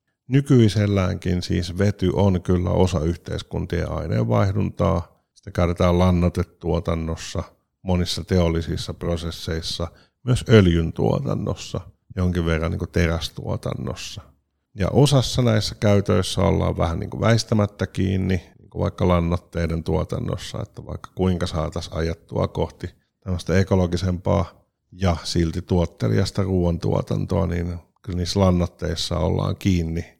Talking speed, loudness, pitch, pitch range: 95 wpm, -22 LUFS, 90 Hz, 85-100 Hz